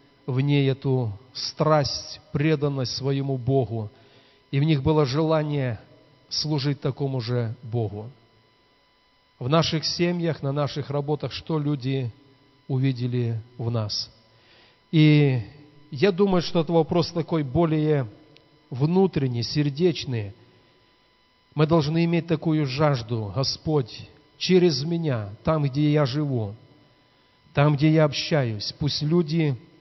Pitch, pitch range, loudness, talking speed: 145 Hz, 125-155 Hz, -24 LUFS, 110 wpm